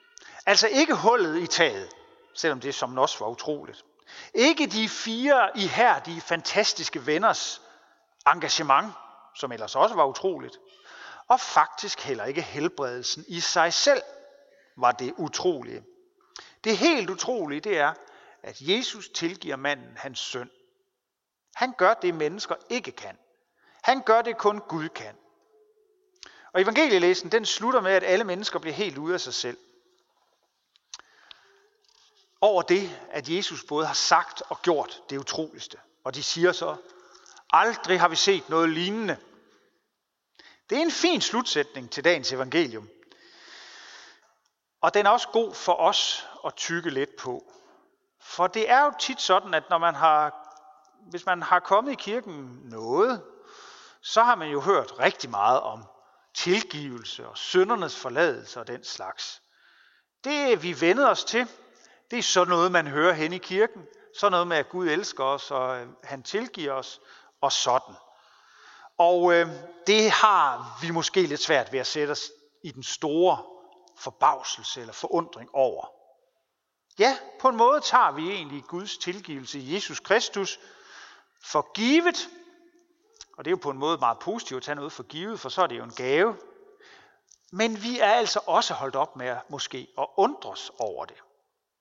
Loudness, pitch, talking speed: -25 LUFS, 200 Hz, 155 wpm